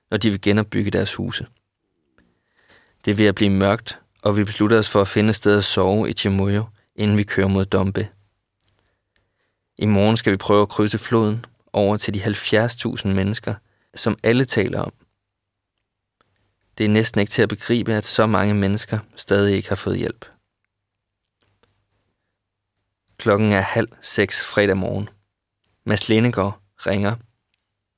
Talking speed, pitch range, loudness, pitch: 155 wpm, 100-110 Hz, -20 LUFS, 105 Hz